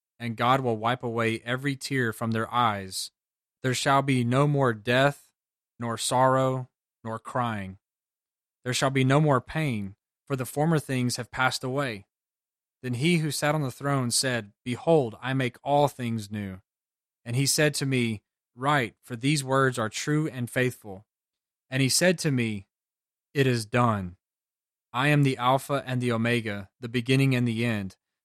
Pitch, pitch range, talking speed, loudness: 125 Hz, 115-140 Hz, 170 wpm, -26 LUFS